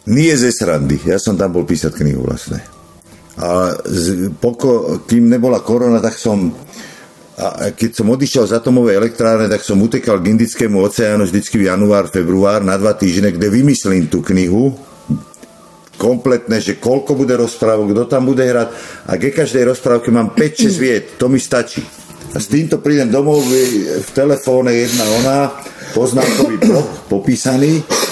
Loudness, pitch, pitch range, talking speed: -14 LUFS, 115 Hz, 100-130 Hz, 160 wpm